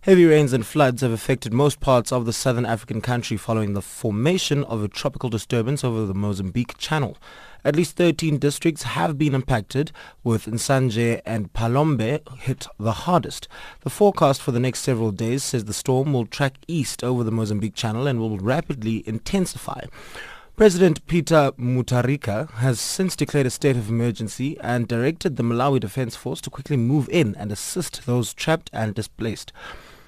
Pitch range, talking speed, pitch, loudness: 115-145 Hz, 170 wpm, 125 Hz, -22 LUFS